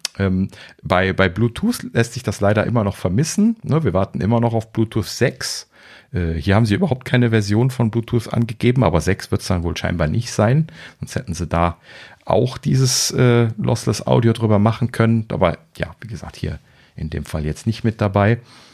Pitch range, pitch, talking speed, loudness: 95-120 Hz, 110 Hz, 185 wpm, -19 LUFS